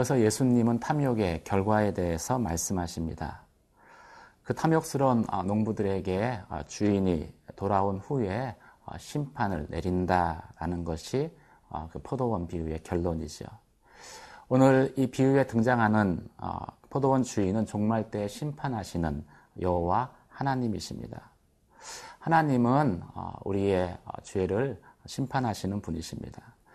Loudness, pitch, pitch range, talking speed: -29 LUFS, 105 Hz, 90-130 Hz, 260 characters per minute